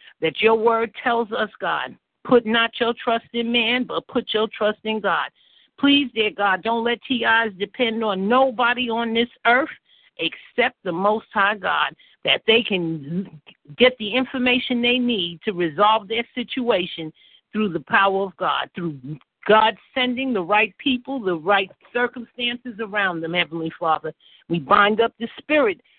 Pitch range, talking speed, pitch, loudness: 195-245 Hz, 160 wpm, 225 Hz, -21 LUFS